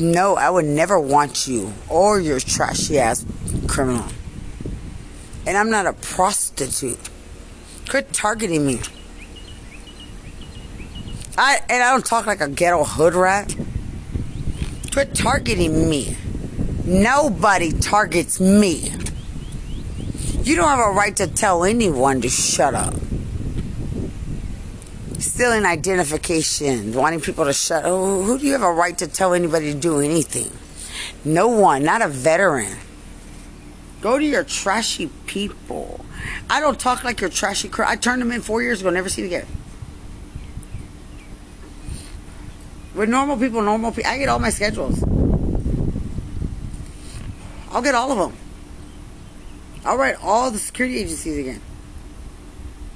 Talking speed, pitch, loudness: 130 wpm, 170 Hz, -19 LUFS